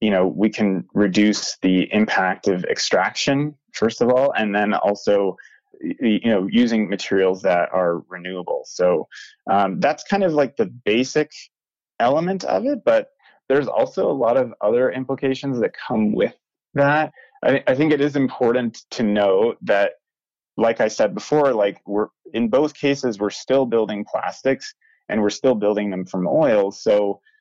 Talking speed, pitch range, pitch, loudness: 165 wpm, 100-145 Hz, 115 Hz, -20 LUFS